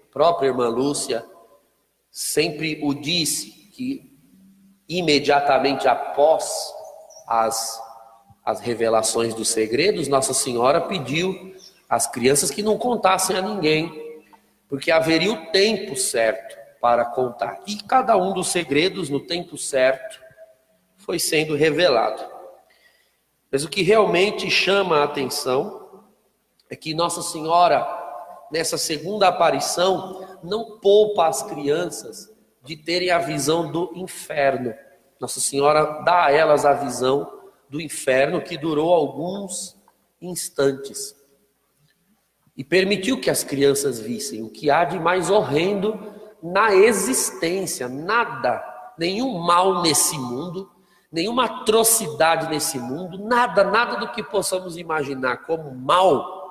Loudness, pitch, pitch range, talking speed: -20 LUFS, 170 Hz, 140-195 Hz, 115 wpm